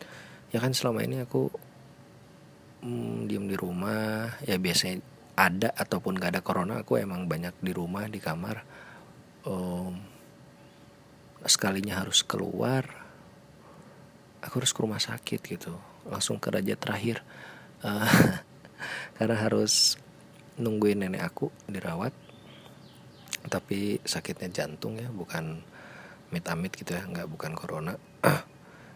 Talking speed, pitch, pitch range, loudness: 115 wpm, 105 Hz, 95-115 Hz, -29 LUFS